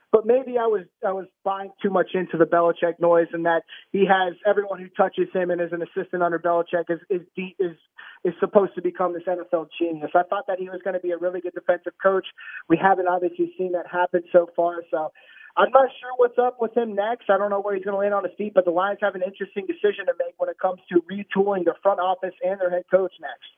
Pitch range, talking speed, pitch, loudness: 175-200 Hz, 250 wpm, 185 Hz, -23 LUFS